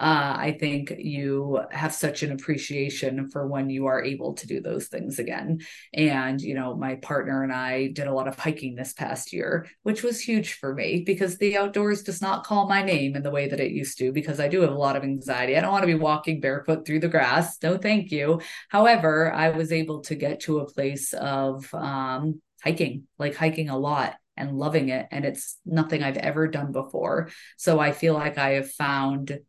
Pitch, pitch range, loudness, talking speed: 150 Hz, 135-160 Hz, -25 LUFS, 220 wpm